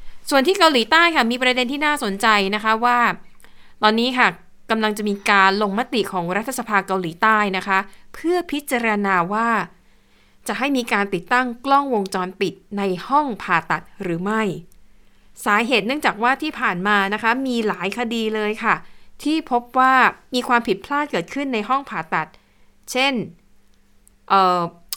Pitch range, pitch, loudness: 195-250 Hz, 215 Hz, -19 LUFS